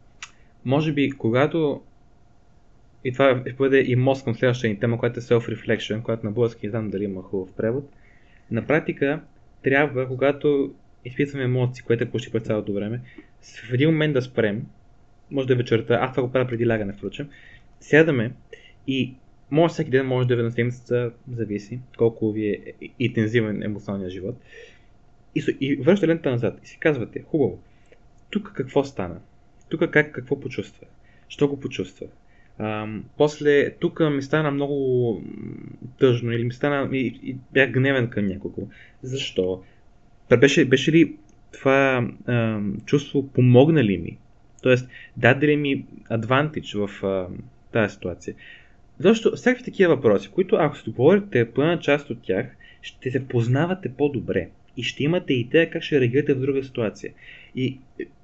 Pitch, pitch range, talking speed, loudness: 125 Hz, 115-140 Hz, 160 wpm, -23 LUFS